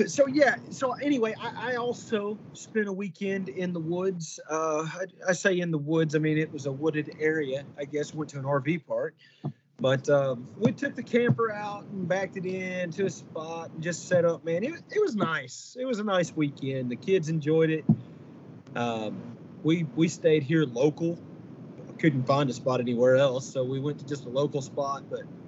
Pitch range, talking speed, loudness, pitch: 145-195 Hz, 205 wpm, -28 LUFS, 160 Hz